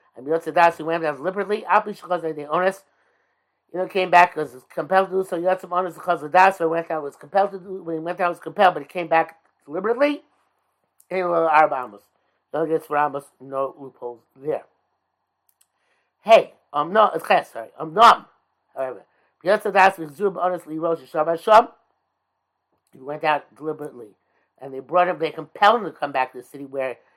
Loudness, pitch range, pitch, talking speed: -21 LUFS, 150-185 Hz, 165 Hz, 170 wpm